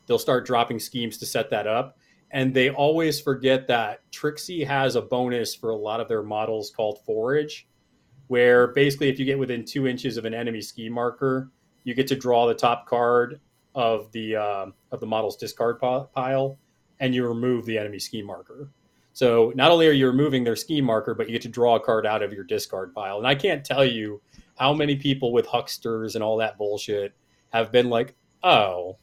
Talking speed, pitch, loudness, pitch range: 205 wpm, 125 Hz, -24 LUFS, 115-135 Hz